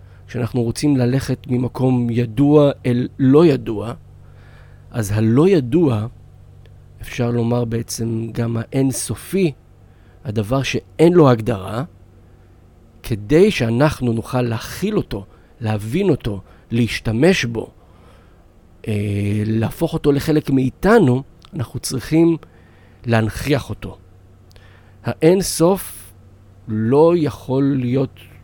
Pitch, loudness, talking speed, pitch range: 115 Hz, -18 LUFS, 85 wpm, 100-135 Hz